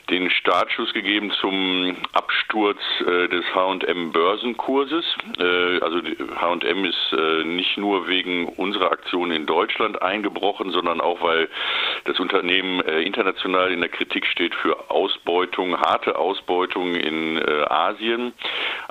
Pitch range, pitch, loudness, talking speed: 90-100 Hz, 90 Hz, -21 LUFS, 130 wpm